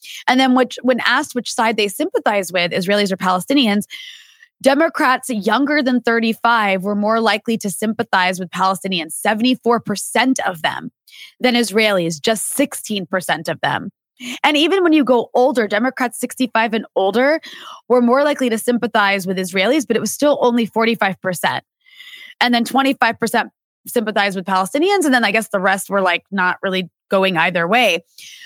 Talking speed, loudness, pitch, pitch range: 160 wpm, -17 LUFS, 230 Hz, 200-260 Hz